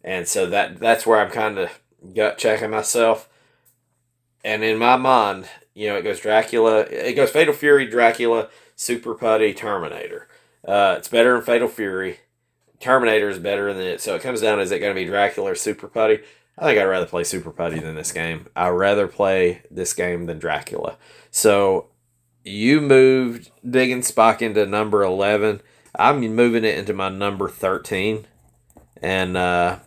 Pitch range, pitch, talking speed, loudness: 100-130 Hz, 115 Hz, 175 wpm, -19 LUFS